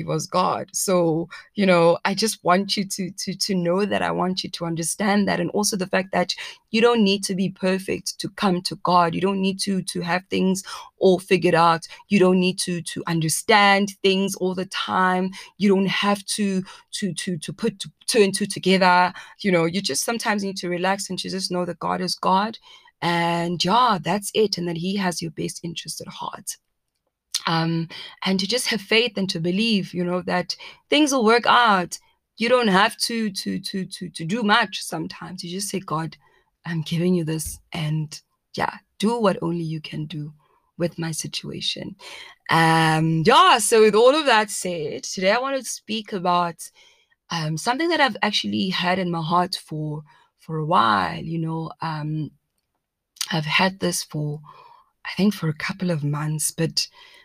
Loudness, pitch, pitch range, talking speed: -22 LUFS, 185 Hz, 170-205 Hz, 195 wpm